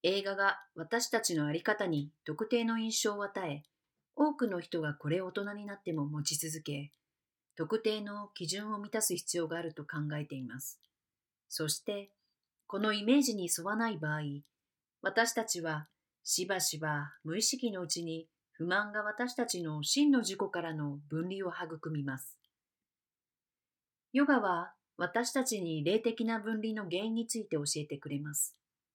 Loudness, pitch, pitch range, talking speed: -34 LUFS, 180 Hz, 155-215 Hz, 285 characters per minute